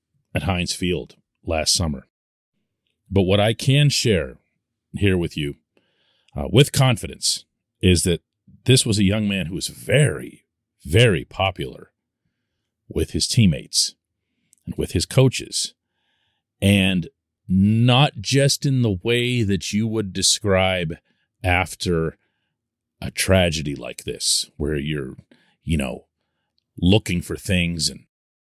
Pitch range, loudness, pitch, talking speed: 85-115 Hz, -20 LUFS, 95 Hz, 120 wpm